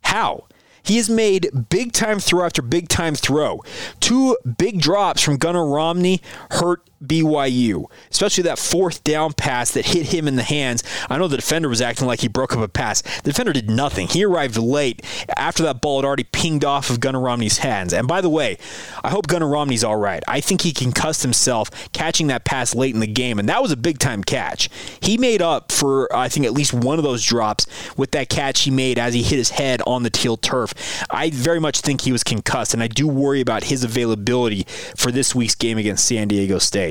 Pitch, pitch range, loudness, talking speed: 135 Hz, 120-160 Hz, -19 LUFS, 220 wpm